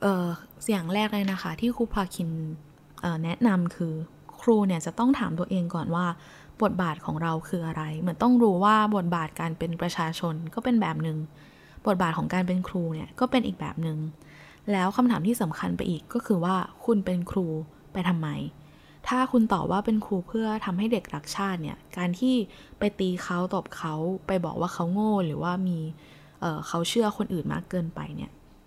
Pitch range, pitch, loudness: 165-205 Hz, 180 Hz, -27 LUFS